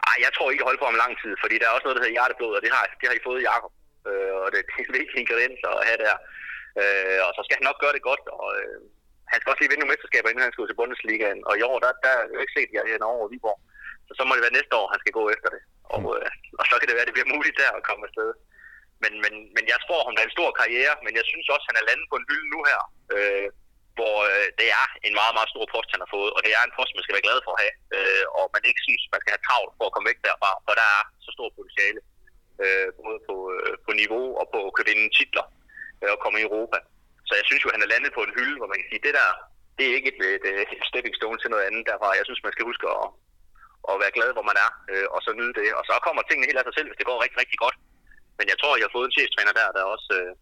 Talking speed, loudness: 305 wpm, -23 LUFS